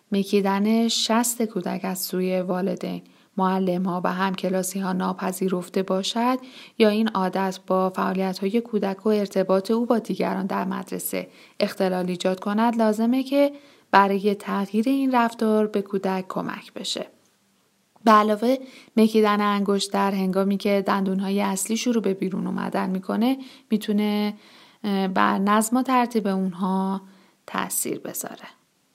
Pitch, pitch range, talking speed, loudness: 200 Hz, 190-220 Hz, 135 wpm, -23 LUFS